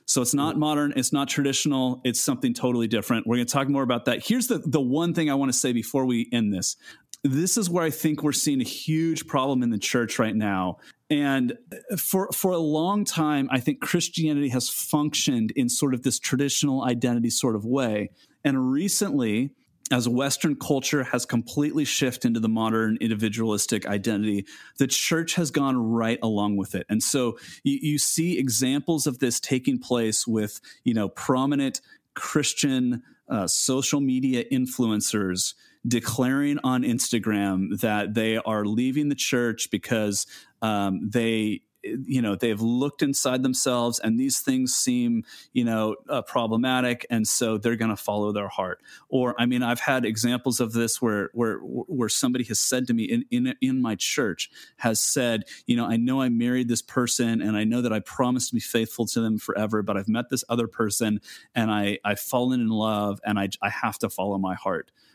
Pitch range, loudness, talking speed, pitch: 110-145 Hz, -25 LUFS, 185 wpm, 125 Hz